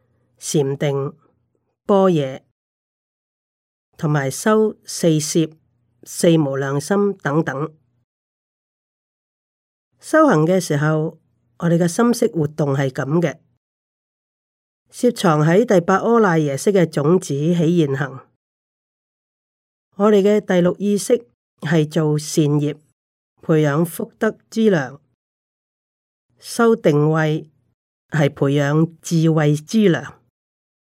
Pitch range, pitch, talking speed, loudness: 145-190 Hz, 160 Hz, 140 characters per minute, -18 LUFS